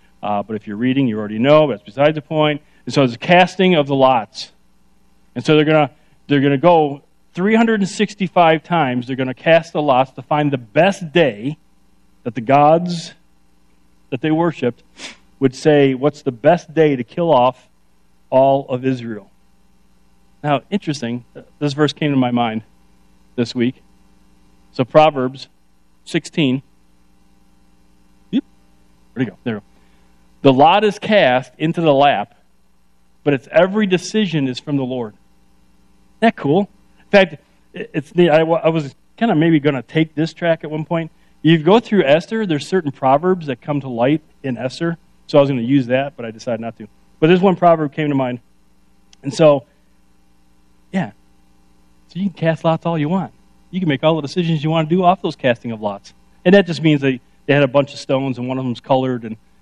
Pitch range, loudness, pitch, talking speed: 110-160 Hz, -17 LUFS, 140 Hz, 185 wpm